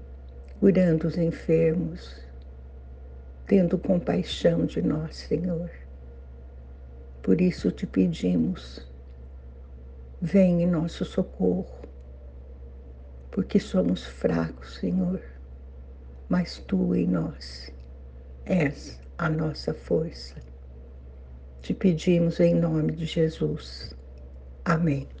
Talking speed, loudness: 85 wpm, -26 LUFS